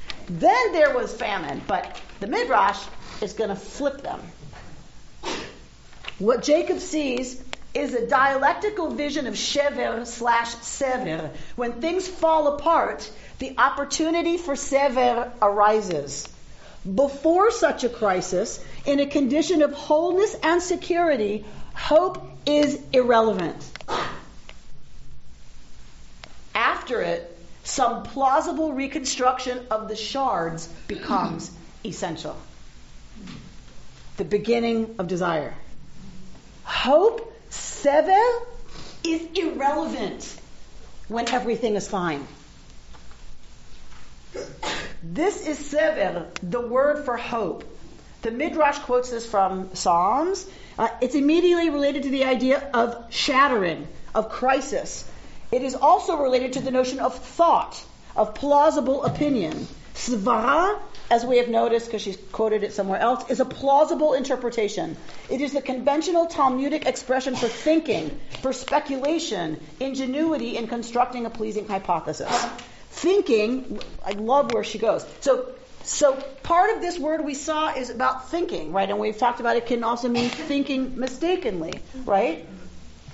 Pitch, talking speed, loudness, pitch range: 255 Hz, 120 wpm, -23 LUFS, 220-295 Hz